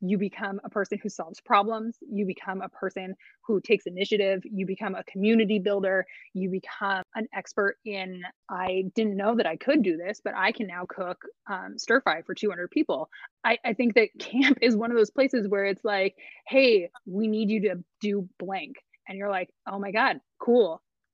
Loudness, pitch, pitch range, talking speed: -27 LUFS, 205 Hz, 190-225 Hz, 200 wpm